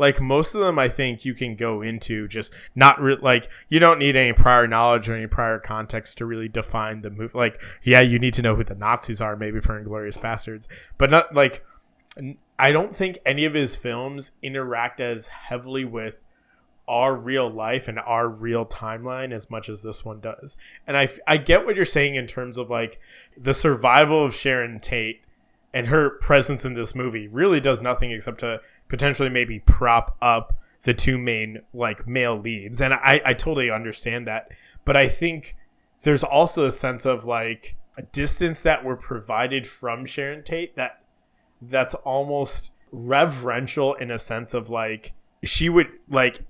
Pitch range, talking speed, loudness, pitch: 115-135 Hz, 185 wpm, -21 LUFS, 125 Hz